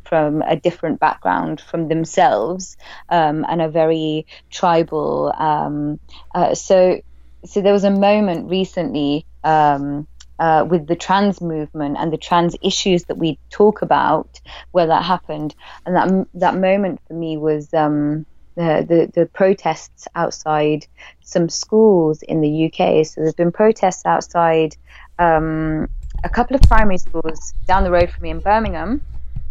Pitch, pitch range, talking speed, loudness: 165 Hz, 155-185 Hz, 150 wpm, -17 LUFS